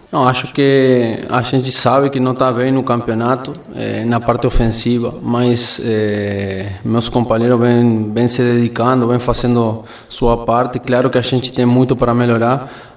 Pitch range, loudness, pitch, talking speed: 115-125 Hz, -15 LUFS, 120 Hz, 160 wpm